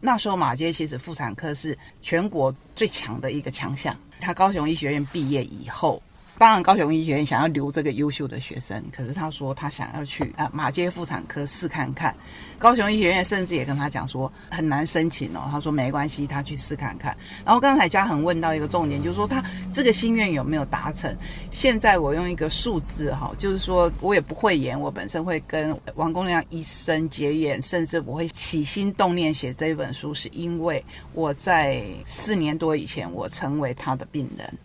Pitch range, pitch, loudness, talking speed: 140-175 Hz, 155 Hz, -23 LUFS, 305 characters per minute